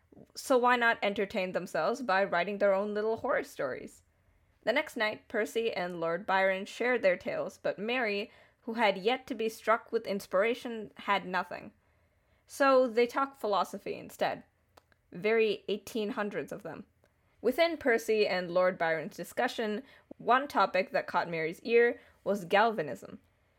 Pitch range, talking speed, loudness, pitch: 195-245 Hz, 145 wpm, -31 LUFS, 220 Hz